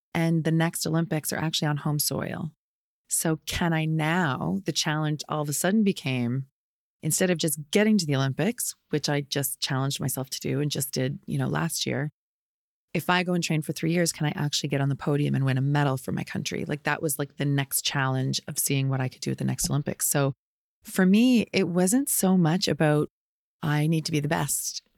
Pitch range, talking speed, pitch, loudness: 140-170 Hz, 225 wpm, 150 Hz, -26 LUFS